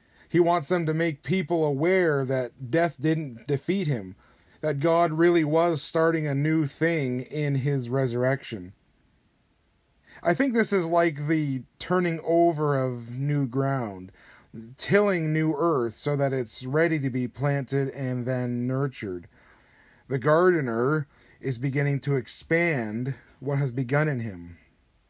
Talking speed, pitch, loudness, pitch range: 140 wpm, 140 Hz, -26 LUFS, 130-165 Hz